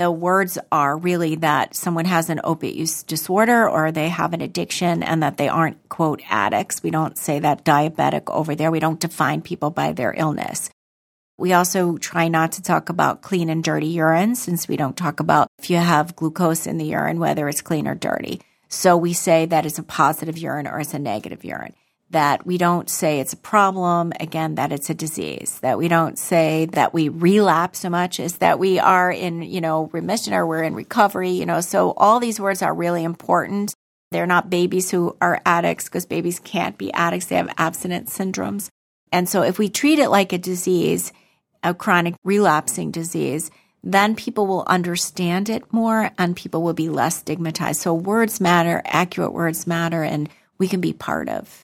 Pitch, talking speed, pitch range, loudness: 170 Hz, 200 wpm, 160-185 Hz, -20 LUFS